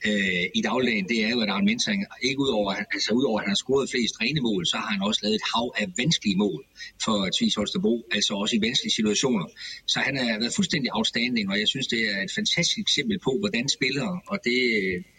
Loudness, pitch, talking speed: -24 LUFS, 190 Hz, 220 wpm